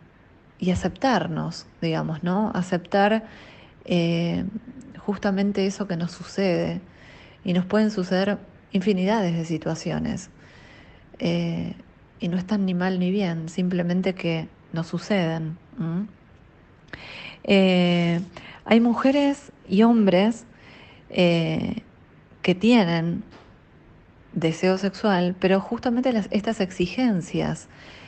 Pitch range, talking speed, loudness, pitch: 170-210 Hz, 100 wpm, -24 LUFS, 185 Hz